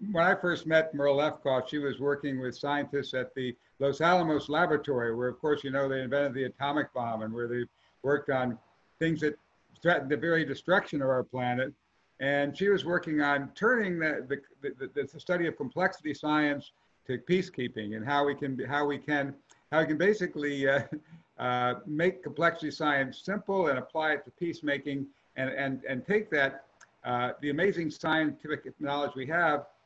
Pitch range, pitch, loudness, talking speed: 135-160 Hz, 145 Hz, -30 LUFS, 185 wpm